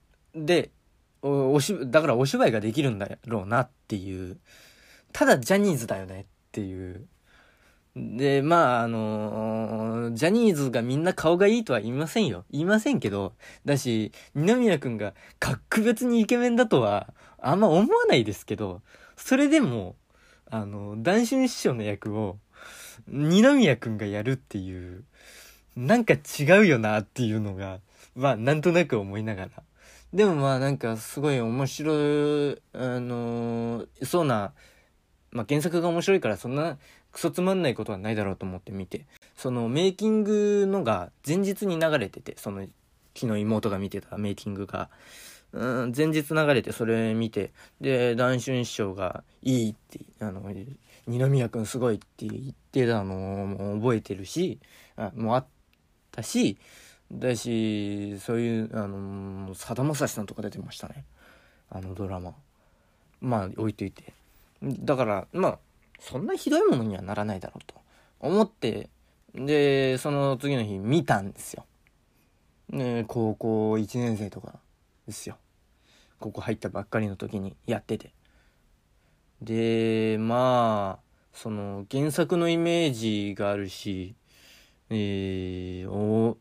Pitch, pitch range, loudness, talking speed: 115 Hz, 100-145 Hz, -26 LUFS, 275 characters per minute